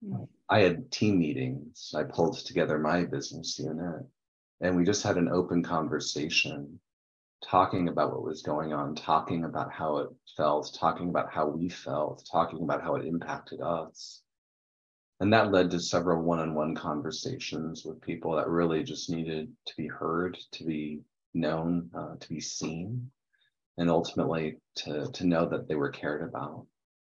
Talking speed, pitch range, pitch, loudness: 165 wpm, 80-90 Hz, 85 Hz, -30 LUFS